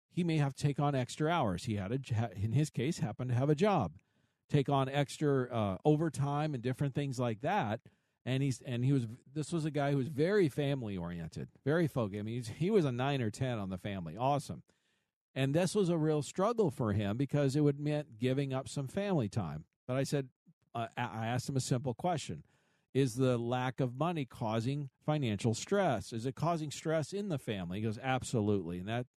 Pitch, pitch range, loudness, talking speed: 135 Hz, 120-150 Hz, -34 LUFS, 215 wpm